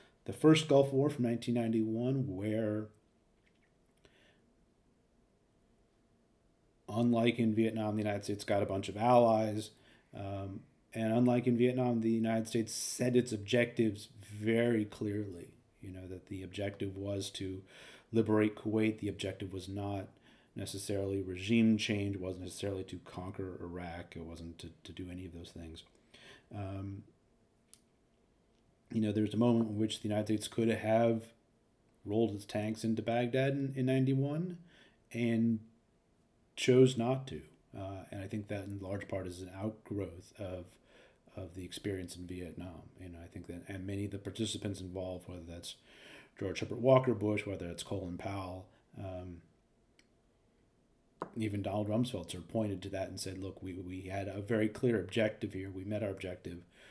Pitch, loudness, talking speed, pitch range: 105 Hz, -35 LUFS, 160 wpm, 95-115 Hz